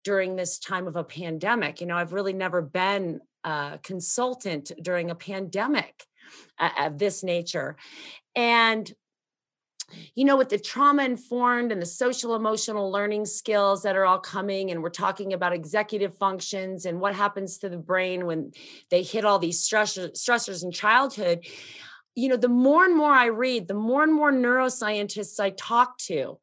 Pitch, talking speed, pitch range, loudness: 200 Hz, 170 wpm, 180-235 Hz, -25 LUFS